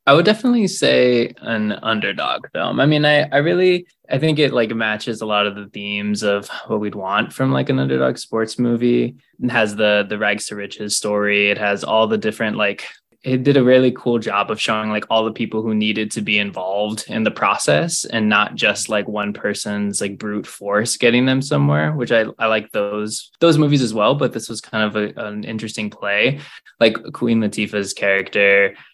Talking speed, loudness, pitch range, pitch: 205 wpm, -18 LUFS, 105-120 Hz, 110 Hz